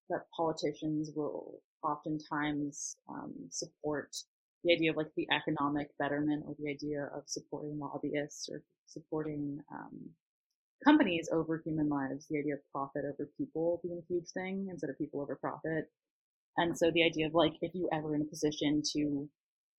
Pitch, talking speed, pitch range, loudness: 150 Hz, 165 wpm, 145-160 Hz, -35 LUFS